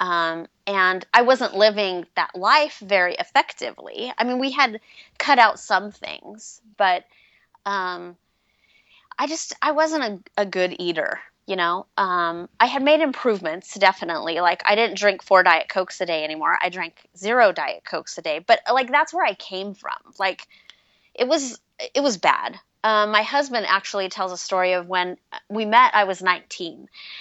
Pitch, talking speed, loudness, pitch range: 205 Hz, 175 wpm, -21 LUFS, 185-260 Hz